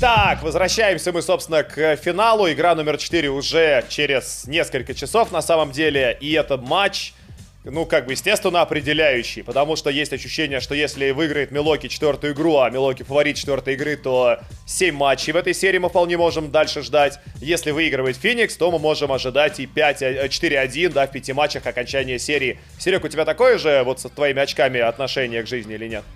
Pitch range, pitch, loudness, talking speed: 135-165 Hz, 145 Hz, -19 LUFS, 180 wpm